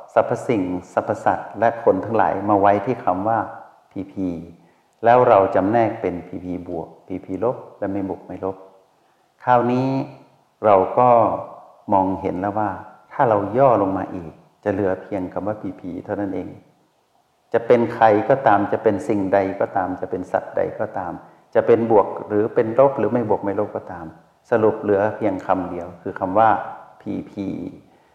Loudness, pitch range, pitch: -20 LUFS, 90-105 Hz, 95 Hz